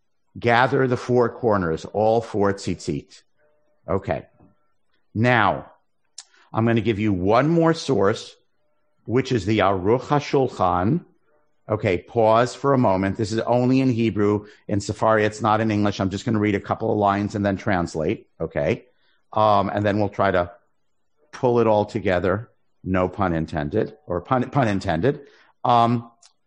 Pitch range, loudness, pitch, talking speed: 100-125 Hz, -22 LUFS, 110 Hz, 155 wpm